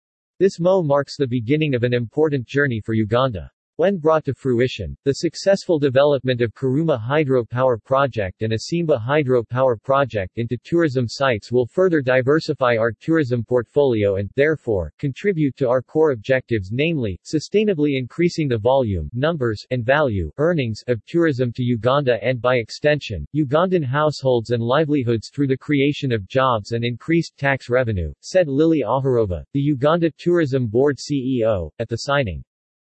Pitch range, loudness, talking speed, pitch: 120-150 Hz, -20 LUFS, 150 wpm, 130 Hz